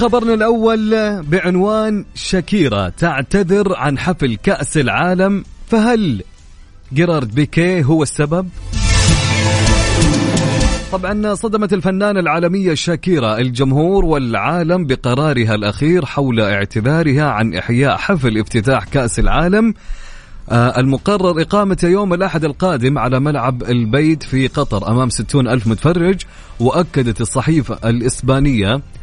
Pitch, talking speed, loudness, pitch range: 145 Hz, 100 wpm, -15 LUFS, 120-185 Hz